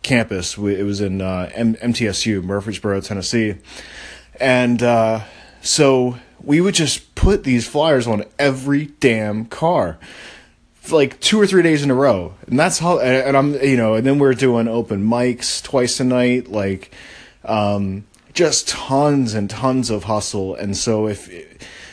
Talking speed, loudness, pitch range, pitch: 160 wpm, -17 LUFS, 105-135 Hz, 115 Hz